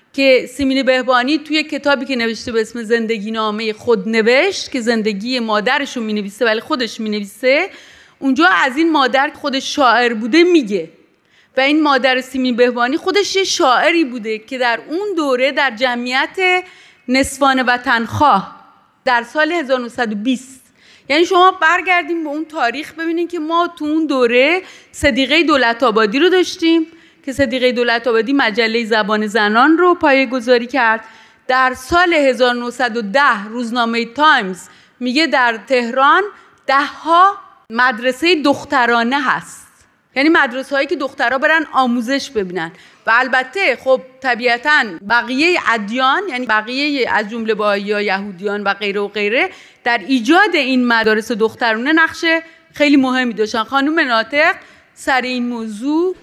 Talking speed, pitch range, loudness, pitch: 140 wpm, 235-305 Hz, -15 LUFS, 260 Hz